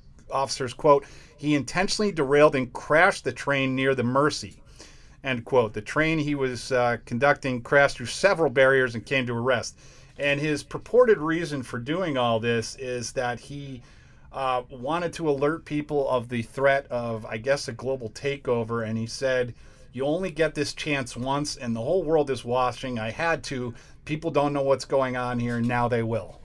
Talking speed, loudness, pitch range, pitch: 190 wpm, -25 LUFS, 120-145 Hz, 135 Hz